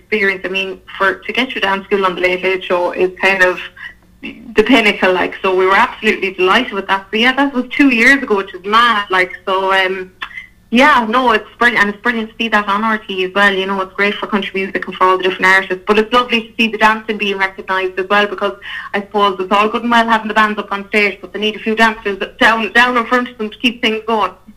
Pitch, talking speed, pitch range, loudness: 205 Hz, 265 wpm, 190-225 Hz, -13 LUFS